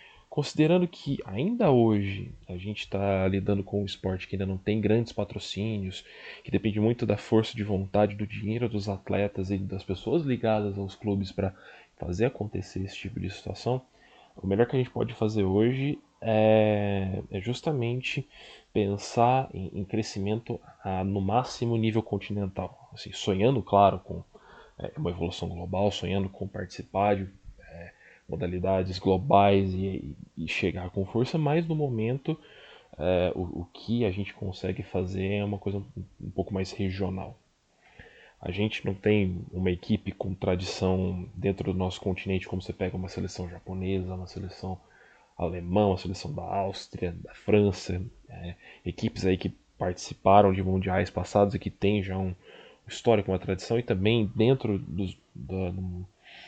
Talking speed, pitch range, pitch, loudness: 150 wpm, 95-110 Hz, 100 Hz, -29 LUFS